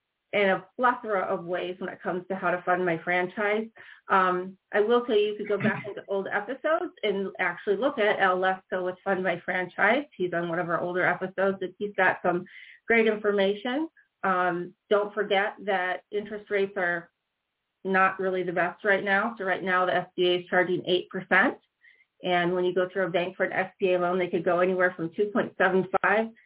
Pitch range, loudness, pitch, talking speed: 180-205 Hz, -26 LUFS, 190 Hz, 195 wpm